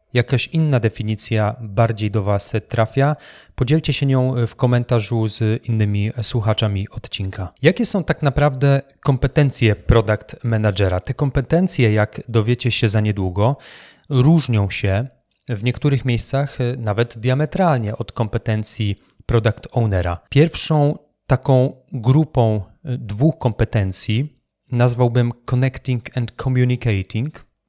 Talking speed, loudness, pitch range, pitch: 110 wpm, -19 LUFS, 110-135 Hz, 120 Hz